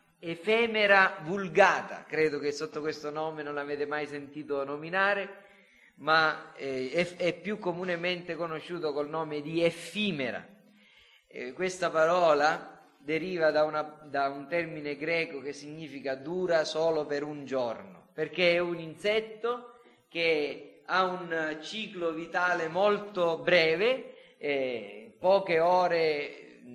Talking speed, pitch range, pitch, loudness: 115 wpm, 150-185 Hz, 165 Hz, -29 LUFS